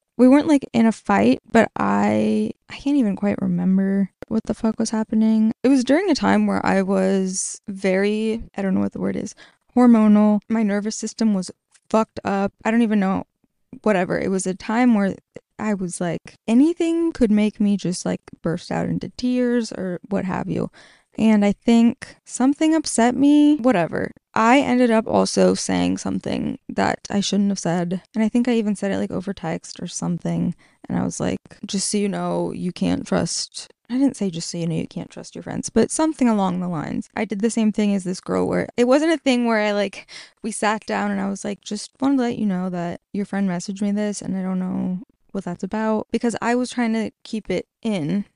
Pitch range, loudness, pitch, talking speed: 190-235 Hz, -21 LUFS, 210 Hz, 220 wpm